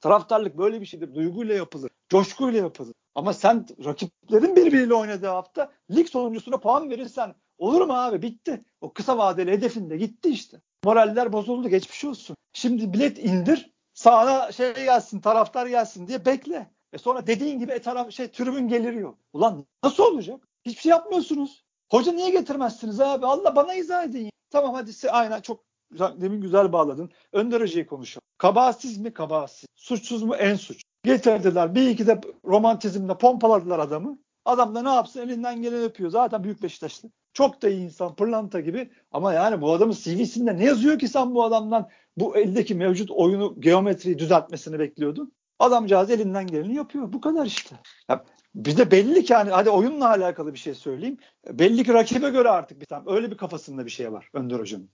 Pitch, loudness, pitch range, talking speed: 225 Hz, -23 LUFS, 190-255 Hz, 170 wpm